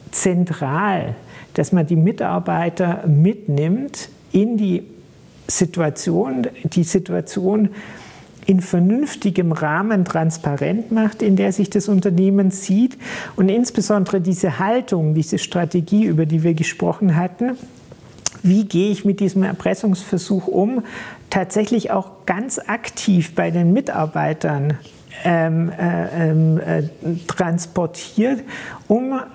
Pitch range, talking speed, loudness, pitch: 170-205 Hz, 105 wpm, -19 LUFS, 190 Hz